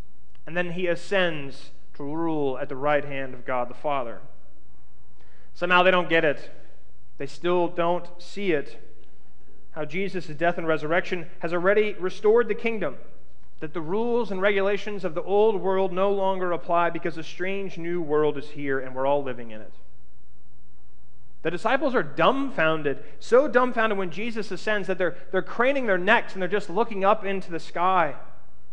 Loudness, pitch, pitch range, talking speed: -25 LUFS, 170 Hz, 135-190 Hz, 170 wpm